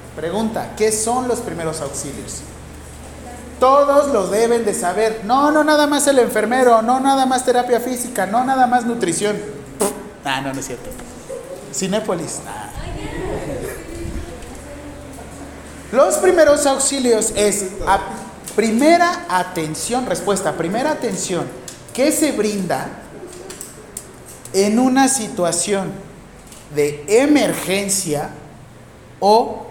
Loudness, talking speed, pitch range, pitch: -17 LUFS, 105 wpm, 175-250 Hz, 210 Hz